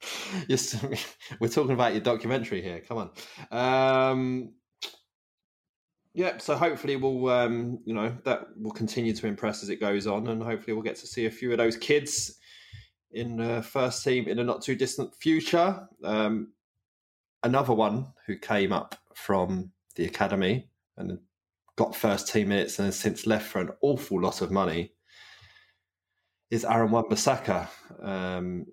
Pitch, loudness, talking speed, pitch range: 115 Hz, -28 LUFS, 160 wpm, 110-130 Hz